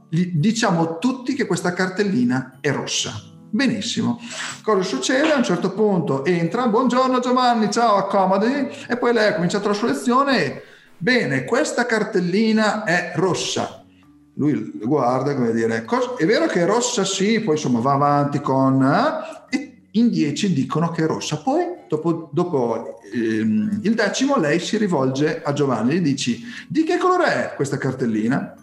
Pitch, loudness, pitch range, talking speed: 195 Hz, -20 LUFS, 145-240 Hz, 155 wpm